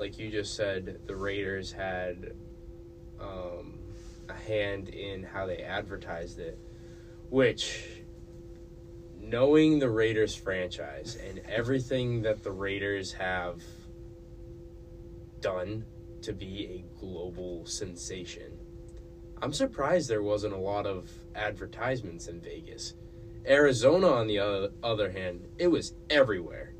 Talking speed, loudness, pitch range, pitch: 110 wpm, -31 LUFS, 85-115 Hz, 100 Hz